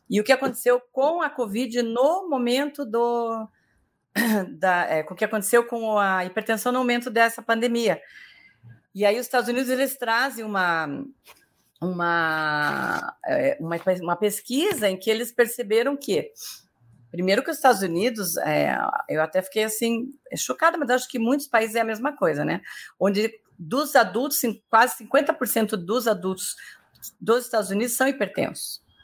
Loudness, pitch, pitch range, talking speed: -23 LUFS, 230 Hz, 200-255 Hz, 155 wpm